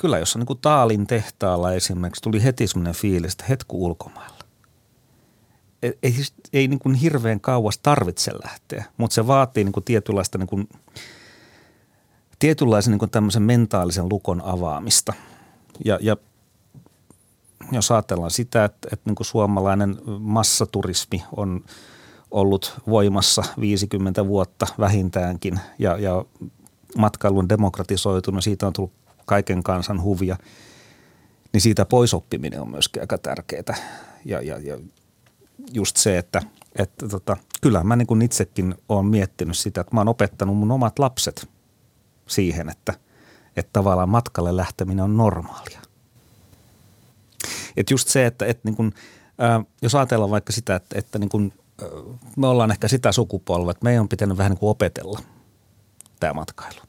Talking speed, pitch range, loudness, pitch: 140 wpm, 95-115 Hz, -21 LUFS, 105 Hz